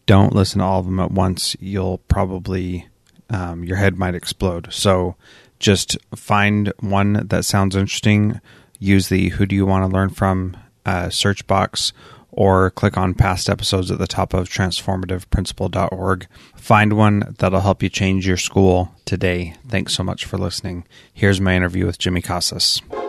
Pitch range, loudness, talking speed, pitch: 90-100 Hz, -18 LUFS, 165 wpm, 95 Hz